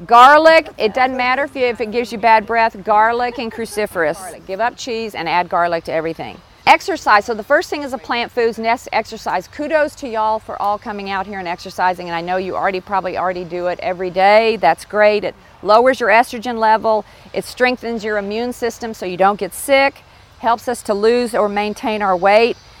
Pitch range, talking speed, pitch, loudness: 195-245 Hz, 210 wpm, 220 Hz, -16 LUFS